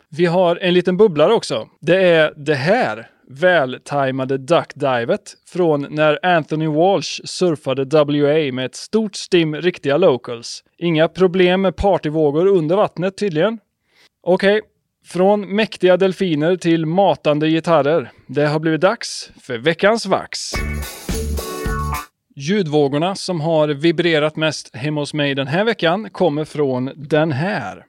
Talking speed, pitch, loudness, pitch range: 130 wpm, 160 Hz, -17 LUFS, 145-185 Hz